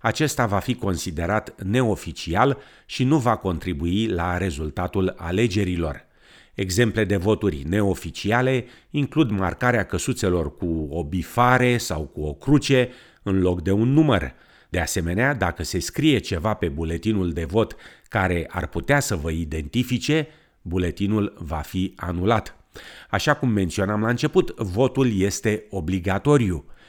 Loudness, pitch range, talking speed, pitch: -23 LUFS, 90-120 Hz, 130 wpm, 100 Hz